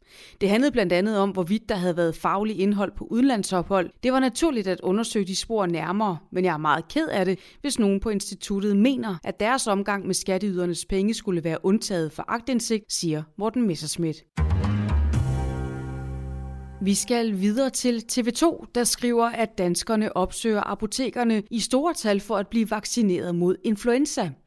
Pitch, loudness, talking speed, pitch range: 200 Hz, -24 LUFS, 165 wpm, 180-225 Hz